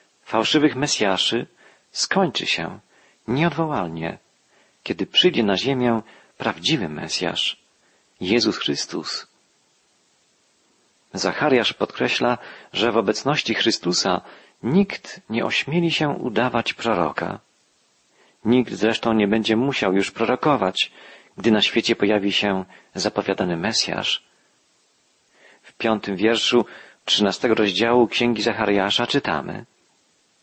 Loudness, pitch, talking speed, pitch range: -21 LUFS, 115 Hz, 95 wpm, 105-125 Hz